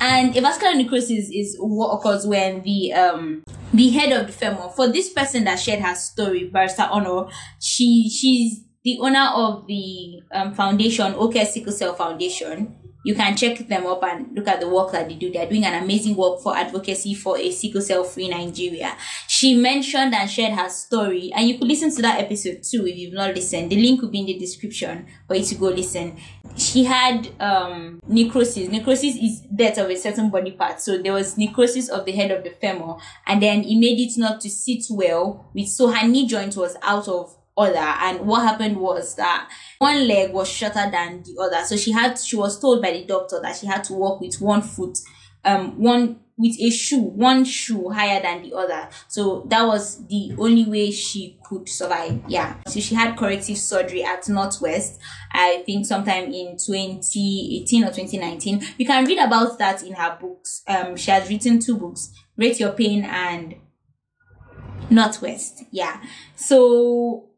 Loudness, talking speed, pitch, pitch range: -20 LUFS, 195 wpm, 205 Hz, 185-230 Hz